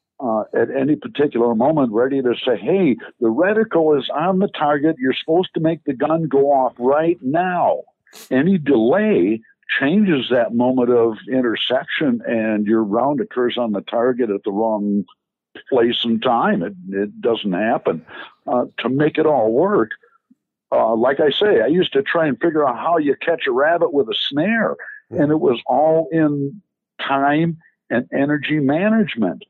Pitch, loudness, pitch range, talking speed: 145 Hz, -18 LUFS, 120-185 Hz, 170 wpm